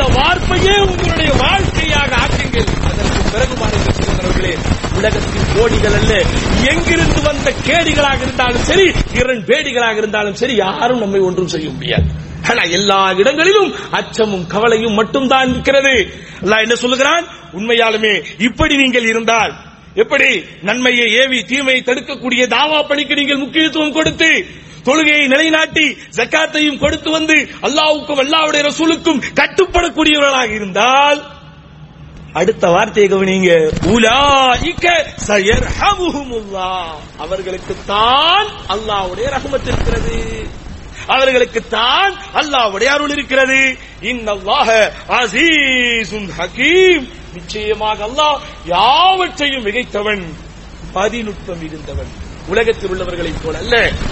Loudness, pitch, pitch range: -13 LUFS, 250 Hz, 205-300 Hz